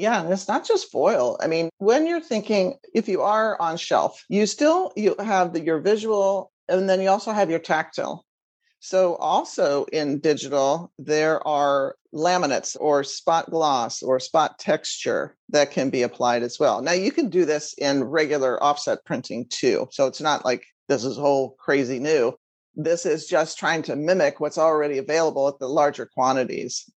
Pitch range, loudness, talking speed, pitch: 145-210 Hz, -22 LUFS, 180 wpm, 165 Hz